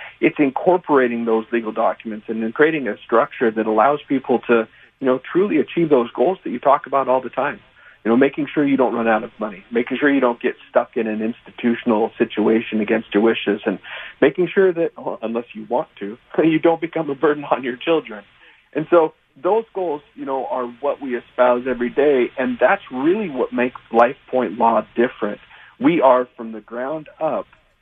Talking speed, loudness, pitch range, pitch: 205 wpm, -19 LUFS, 115-150 Hz, 125 Hz